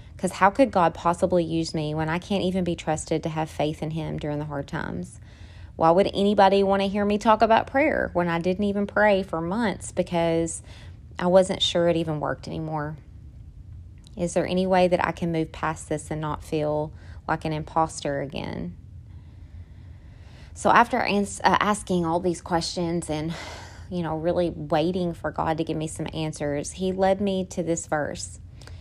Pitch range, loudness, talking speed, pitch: 150-185 Hz, -24 LUFS, 185 wpm, 165 Hz